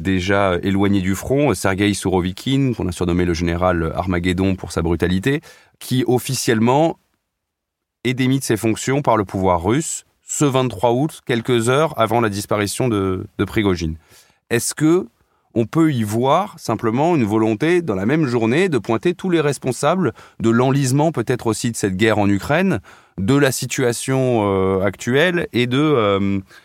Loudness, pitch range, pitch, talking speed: -18 LUFS, 95-130 Hz, 115 Hz, 160 wpm